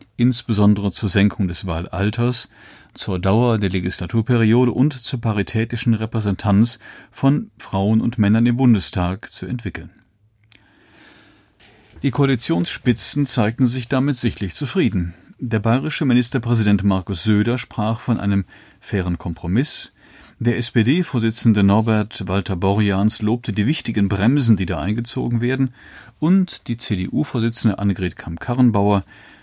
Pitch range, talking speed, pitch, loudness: 100-120 Hz, 110 wpm, 110 Hz, -19 LUFS